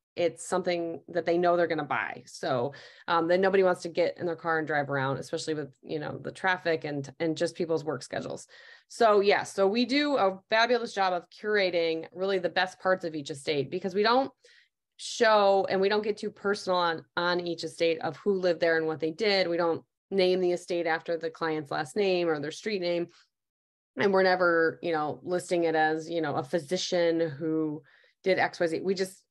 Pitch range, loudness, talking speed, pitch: 160-190 Hz, -28 LUFS, 215 wpm, 175 Hz